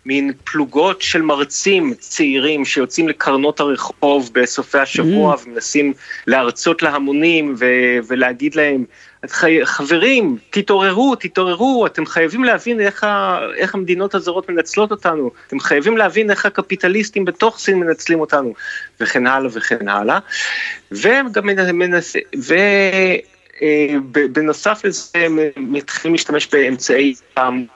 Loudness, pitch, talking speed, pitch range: -15 LUFS, 170 Hz, 100 wpm, 145-205 Hz